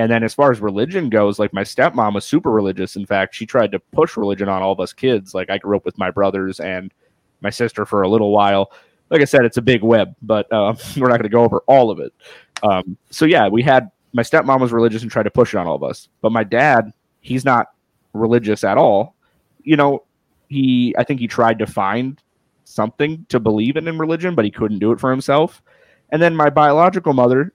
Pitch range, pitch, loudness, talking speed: 100-130 Hz, 115 Hz, -16 LUFS, 240 wpm